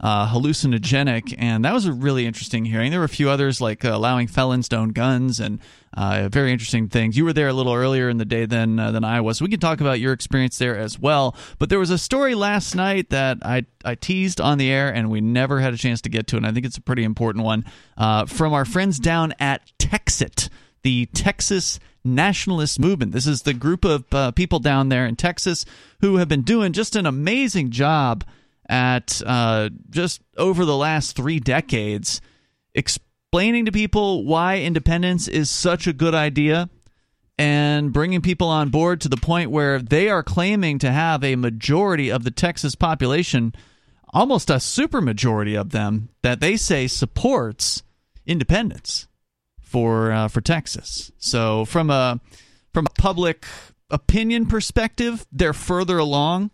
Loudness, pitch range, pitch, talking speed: -20 LUFS, 120-170 Hz, 135 Hz, 185 wpm